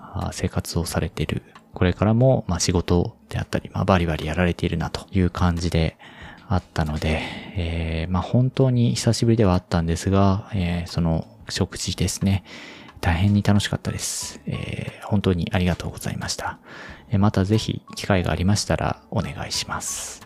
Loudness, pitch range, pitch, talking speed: -23 LUFS, 85-105 Hz, 90 Hz, 340 characters per minute